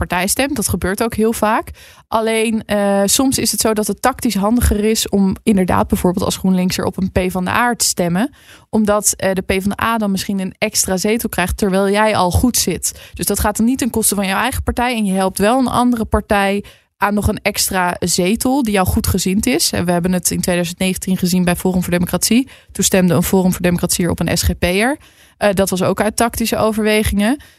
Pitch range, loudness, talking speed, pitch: 185-225 Hz, -16 LUFS, 225 wpm, 205 Hz